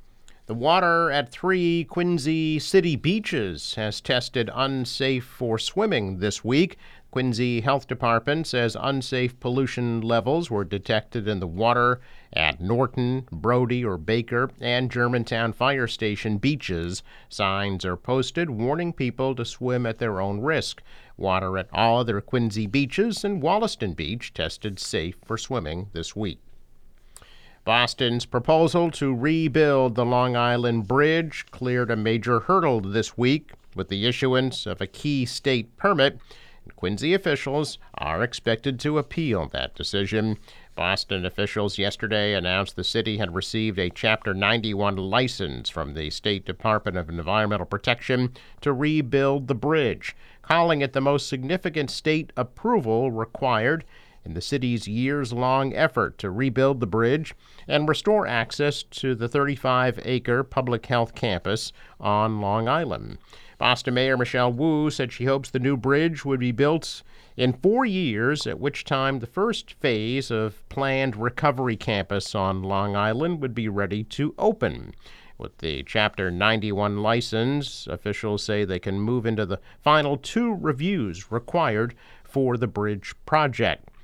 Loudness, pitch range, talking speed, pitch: -24 LUFS, 105-135 Hz, 145 wpm, 120 Hz